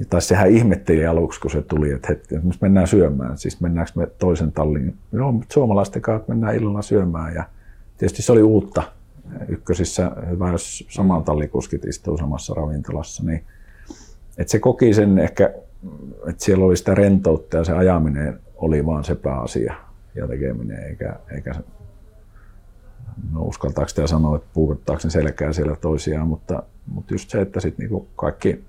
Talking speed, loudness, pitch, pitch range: 160 wpm, -20 LUFS, 90 Hz, 80-100 Hz